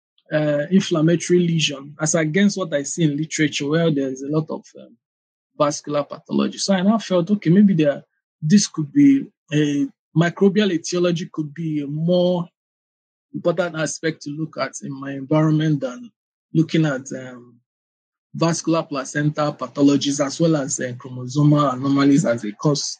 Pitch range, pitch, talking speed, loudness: 140-170 Hz, 155 Hz, 160 wpm, -20 LUFS